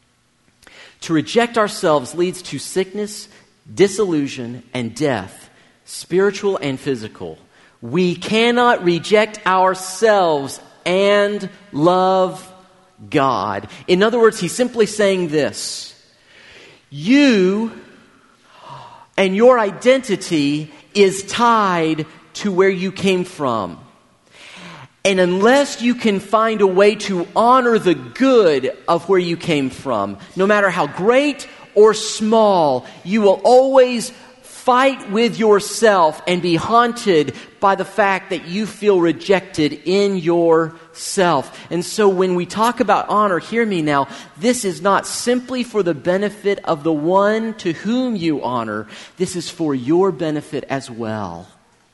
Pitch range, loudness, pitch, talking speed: 165-215 Hz, -17 LUFS, 190 Hz, 125 wpm